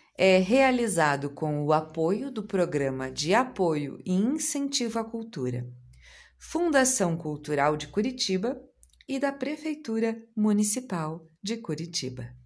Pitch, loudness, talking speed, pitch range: 190 Hz, -27 LUFS, 110 wpm, 150-245 Hz